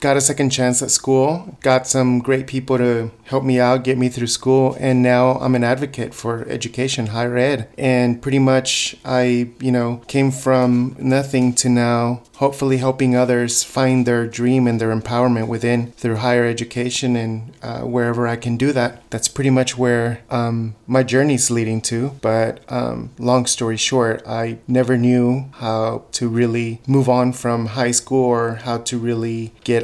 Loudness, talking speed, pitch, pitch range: -18 LUFS, 175 wpm, 125 Hz, 120-130 Hz